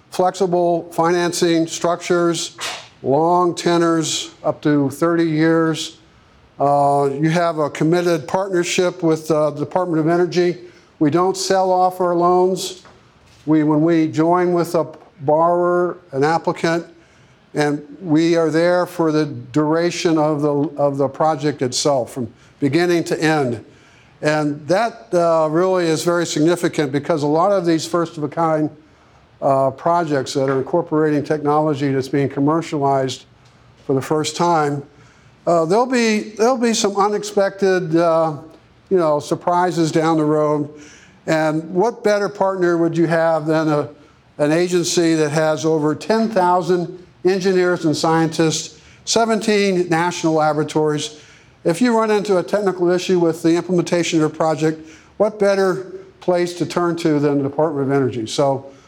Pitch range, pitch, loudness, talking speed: 150-175 Hz, 165 Hz, -18 LUFS, 145 wpm